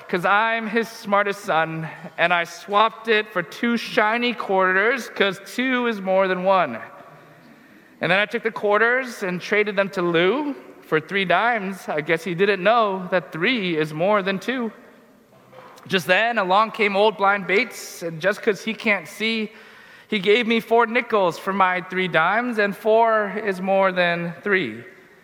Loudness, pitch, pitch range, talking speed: -21 LUFS, 200 Hz, 185-225 Hz, 170 wpm